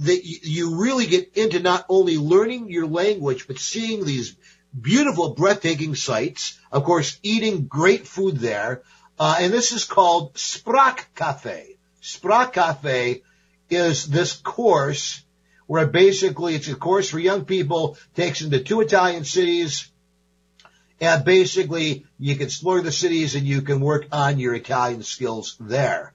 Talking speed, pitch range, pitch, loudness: 145 wpm, 140-185 Hz, 165 Hz, -21 LUFS